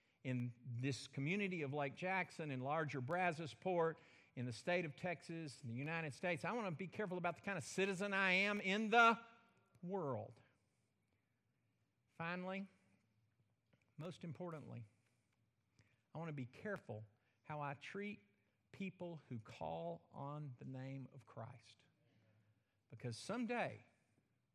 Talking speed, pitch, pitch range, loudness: 130 wpm, 135 Hz, 115-175 Hz, -43 LUFS